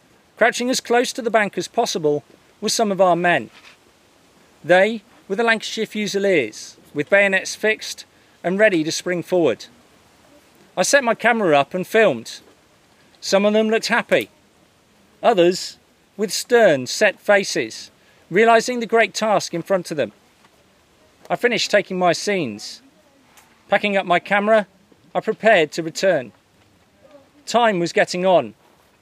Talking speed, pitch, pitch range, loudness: 140 wpm, 205 Hz, 180-225 Hz, -19 LUFS